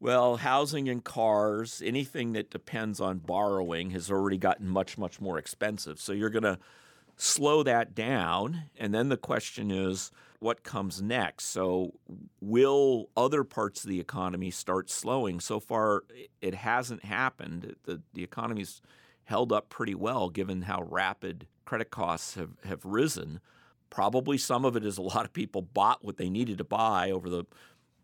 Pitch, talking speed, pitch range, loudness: 105 Hz, 165 wpm, 95-120 Hz, -30 LUFS